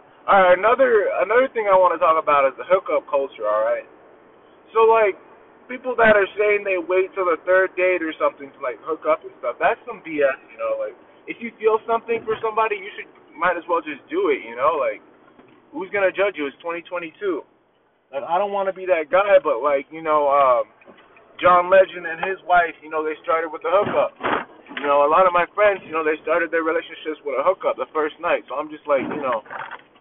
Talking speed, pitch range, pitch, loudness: 220 wpm, 160-225 Hz, 185 Hz, -20 LUFS